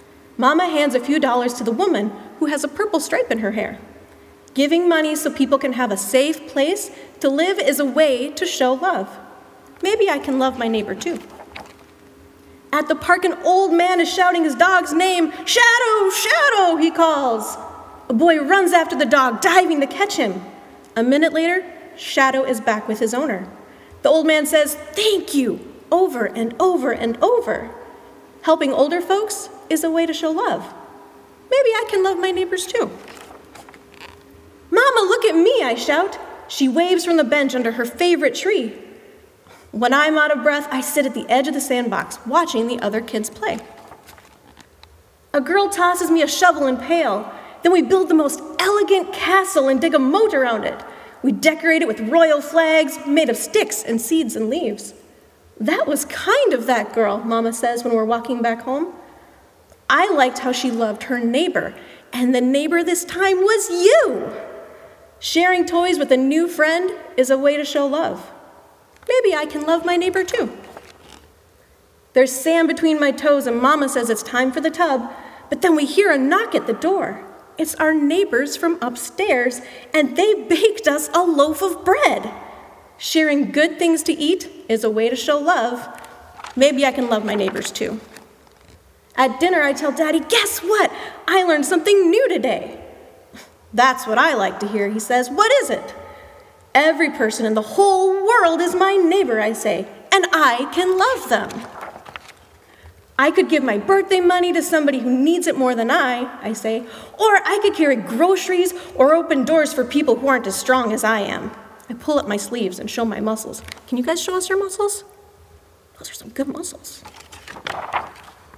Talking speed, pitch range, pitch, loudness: 180 wpm, 255-360 Hz, 305 Hz, -18 LUFS